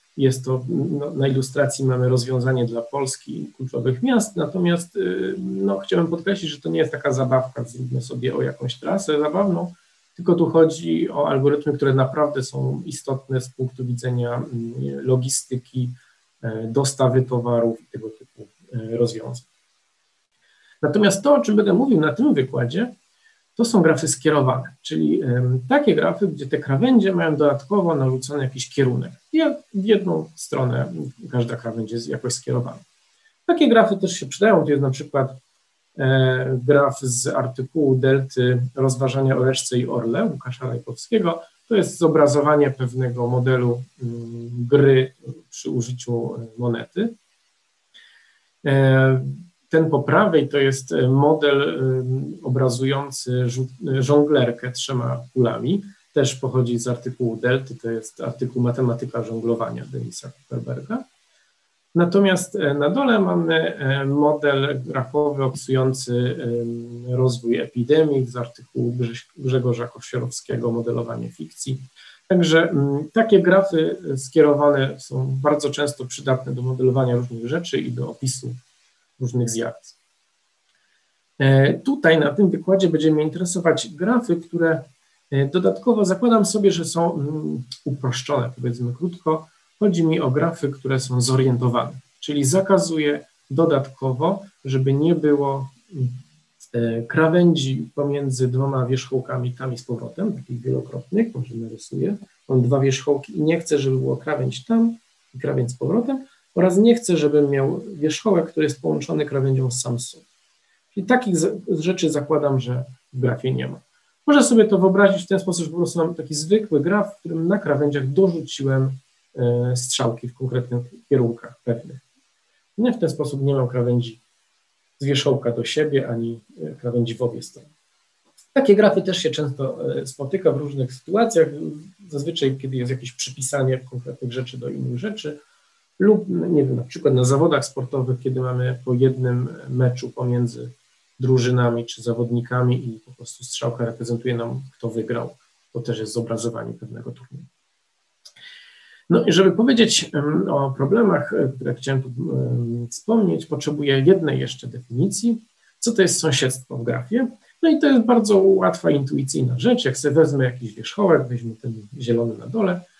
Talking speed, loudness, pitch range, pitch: 140 wpm, -21 LUFS, 125-160 Hz, 135 Hz